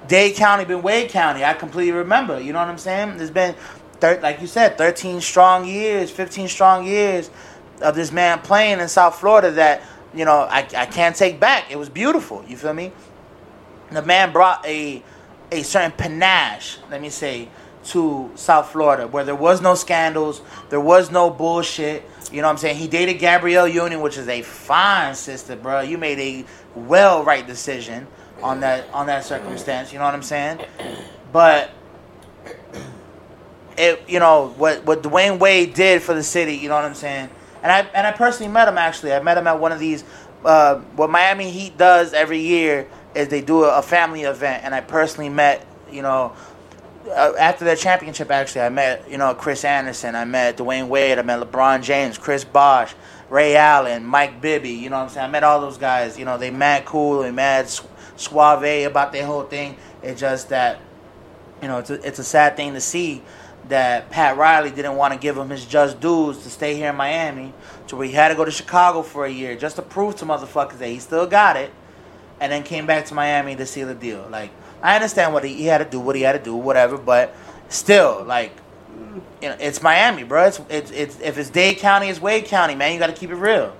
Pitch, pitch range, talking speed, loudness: 150 Hz, 140-175 Hz, 215 wpm, -17 LUFS